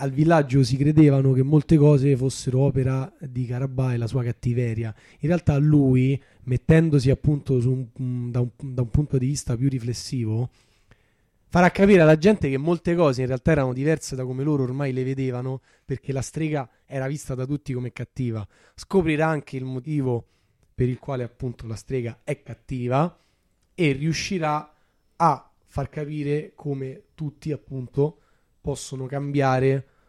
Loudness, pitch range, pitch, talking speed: -23 LUFS, 125-150 Hz, 135 Hz, 160 wpm